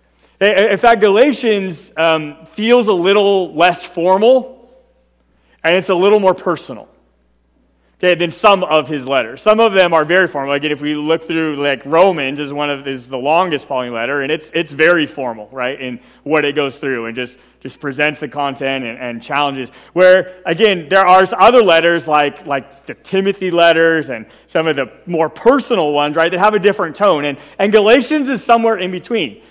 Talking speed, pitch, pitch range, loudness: 190 wpm, 165 Hz, 140-195 Hz, -14 LUFS